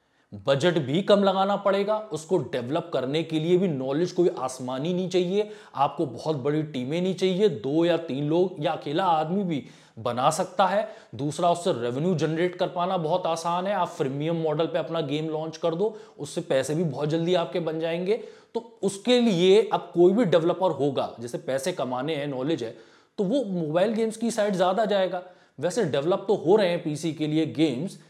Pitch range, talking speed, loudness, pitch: 155-190 Hz, 195 wpm, -25 LUFS, 175 Hz